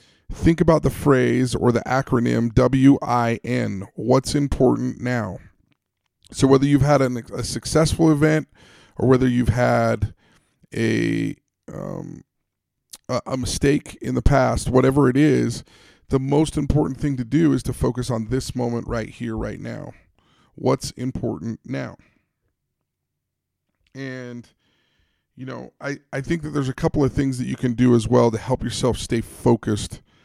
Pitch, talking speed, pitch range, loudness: 125 Hz, 155 wpm, 120-135 Hz, -21 LUFS